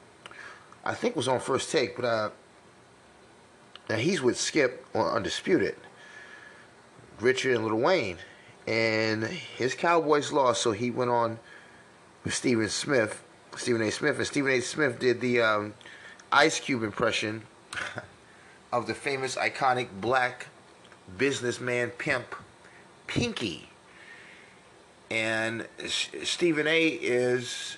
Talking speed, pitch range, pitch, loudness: 115 wpm, 110-130 Hz, 120 Hz, -27 LUFS